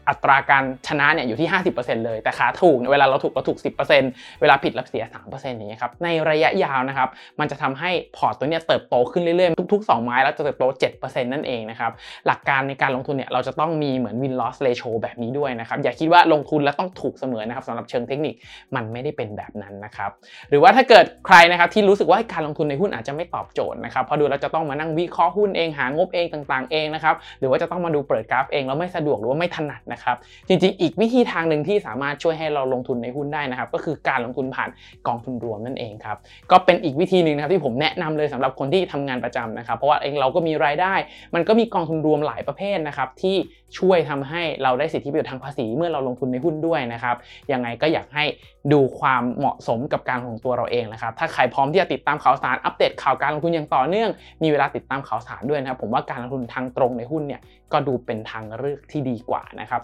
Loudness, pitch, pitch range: -21 LUFS, 145 Hz, 125-165 Hz